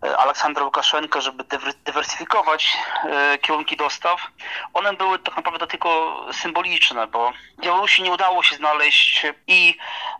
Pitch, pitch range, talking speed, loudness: 165 Hz, 150-185 Hz, 110 wpm, -18 LUFS